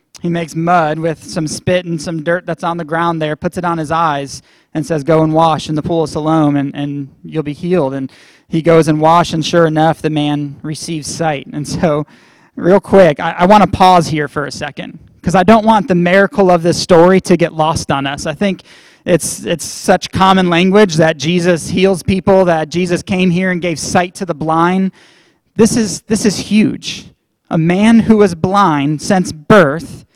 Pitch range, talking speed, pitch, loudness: 155-185 Hz, 210 wpm, 170 Hz, -13 LUFS